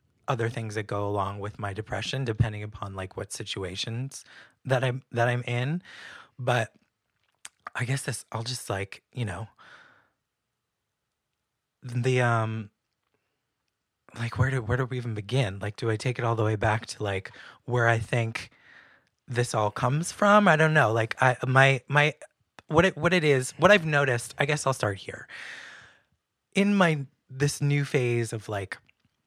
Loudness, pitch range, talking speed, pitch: -26 LUFS, 110-135 Hz, 170 wpm, 120 Hz